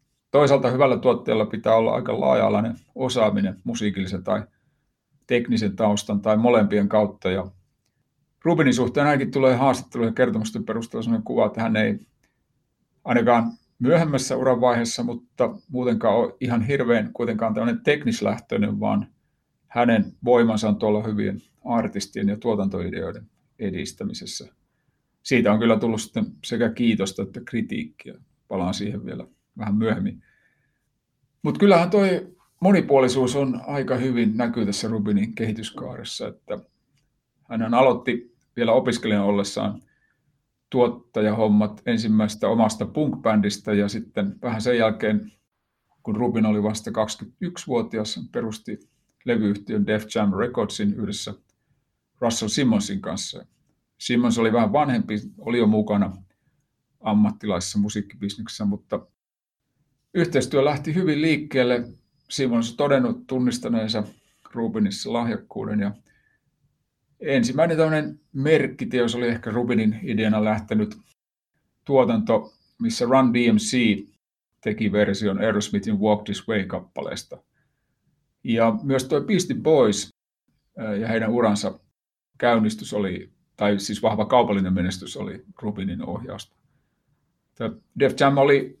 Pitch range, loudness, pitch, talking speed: 105-135 Hz, -23 LUFS, 115 Hz, 110 wpm